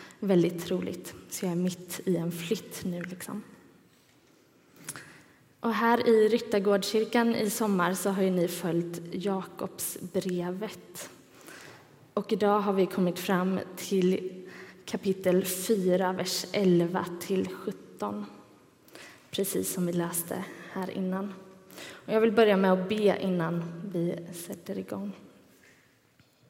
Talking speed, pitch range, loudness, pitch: 115 wpm, 175-200 Hz, -29 LUFS, 185 Hz